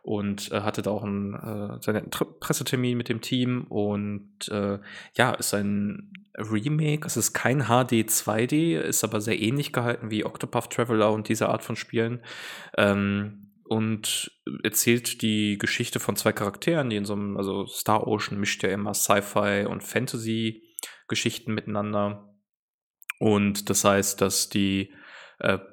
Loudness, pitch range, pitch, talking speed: -26 LUFS, 100-120 Hz, 110 Hz, 145 wpm